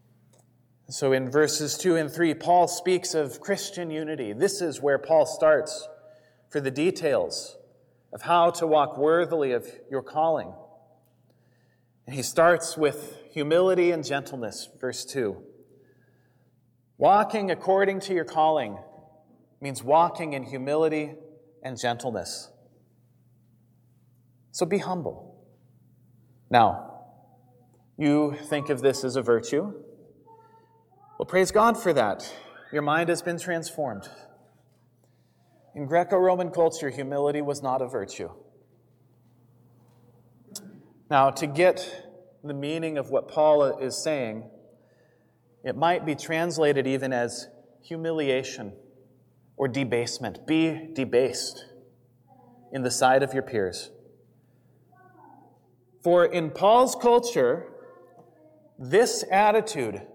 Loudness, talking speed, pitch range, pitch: -25 LUFS, 110 wpm, 125-170 Hz, 145 Hz